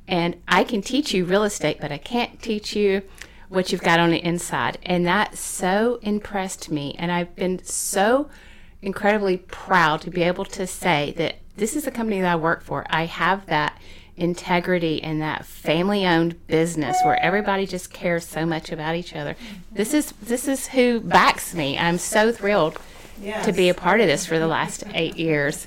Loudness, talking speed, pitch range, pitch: -22 LUFS, 190 wpm, 165-205 Hz, 180 Hz